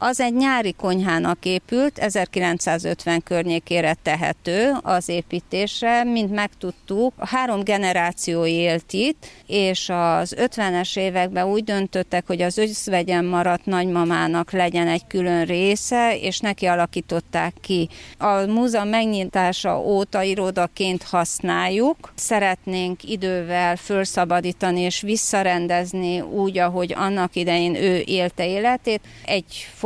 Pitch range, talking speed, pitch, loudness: 175-205 Hz, 110 wpm, 185 Hz, -21 LUFS